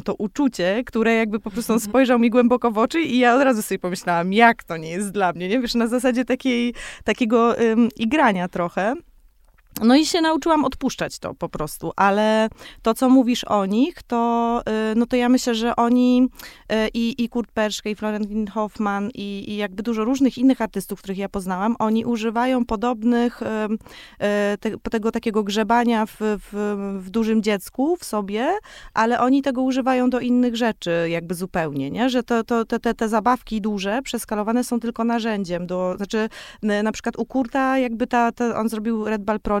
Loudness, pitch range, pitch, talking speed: -21 LUFS, 210-245 Hz, 230 Hz, 185 wpm